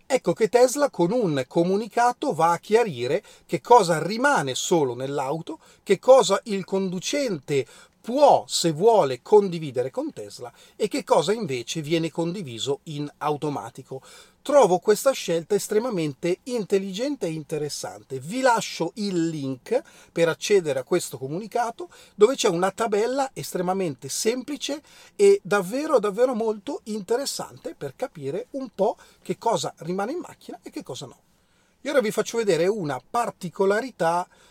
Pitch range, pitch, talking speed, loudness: 165-245 Hz, 200 Hz, 135 wpm, -23 LUFS